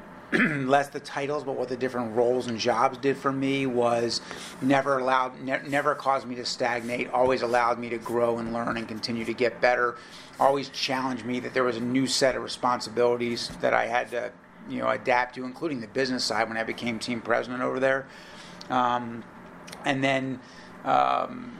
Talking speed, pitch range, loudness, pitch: 190 wpm, 120-135 Hz, -26 LUFS, 125 Hz